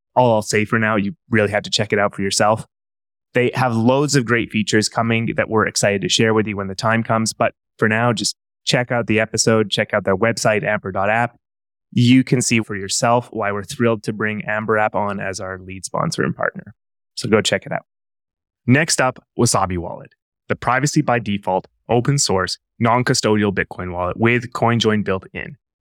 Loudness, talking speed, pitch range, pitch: -18 LUFS, 200 wpm, 100-120 Hz, 110 Hz